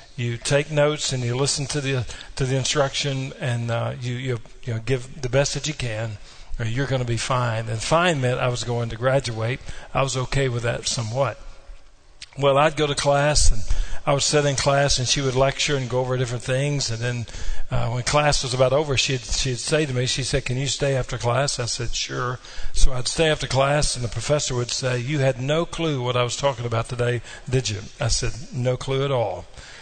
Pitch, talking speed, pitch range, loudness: 130 Hz, 230 wpm, 120-140 Hz, -23 LUFS